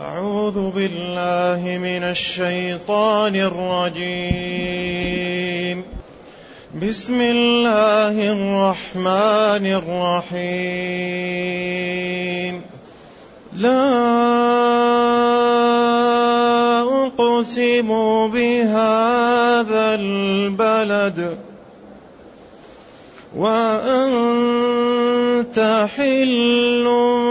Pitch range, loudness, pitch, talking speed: 180-240 Hz, -18 LUFS, 215 Hz, 35 wpm